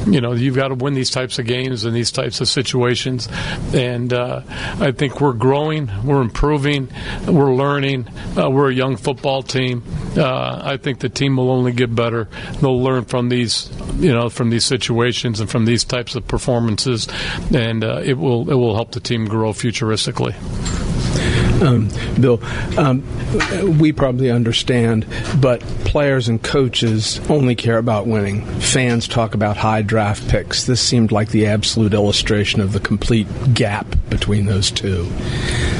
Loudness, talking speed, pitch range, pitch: -17 LUFS, 165 wpm, 110-130 Hz, 120 Hz